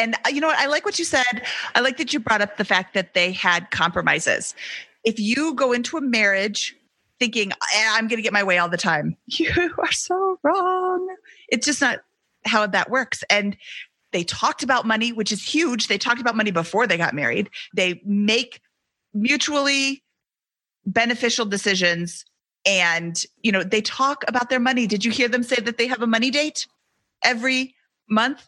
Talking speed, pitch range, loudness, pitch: 185 wpm, 205-265 Hz, -21 LUFS, 235 Hz